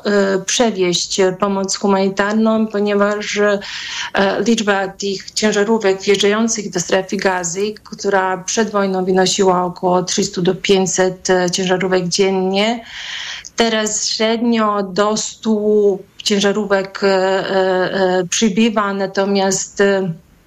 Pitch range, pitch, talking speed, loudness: 190-210 Hz, 195 Hz, 80 wpm, -16 LUFS